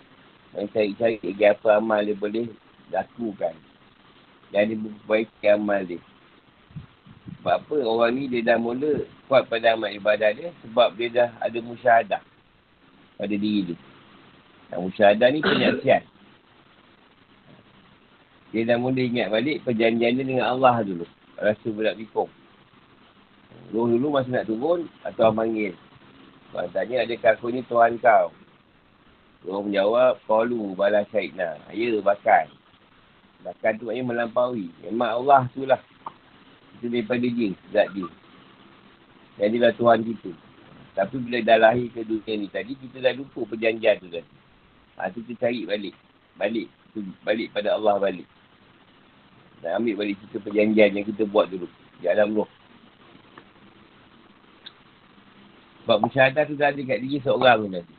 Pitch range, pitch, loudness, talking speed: 100-120 Hz, 110 Hz, -23 LUFS, 140 wpm